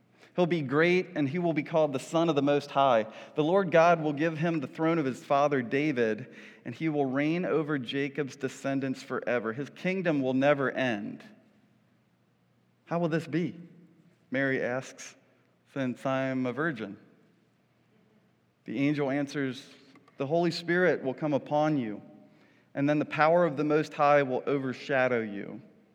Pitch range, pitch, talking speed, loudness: 135-165 Hz, 145 Hz, 160 wpm, -28 LUFS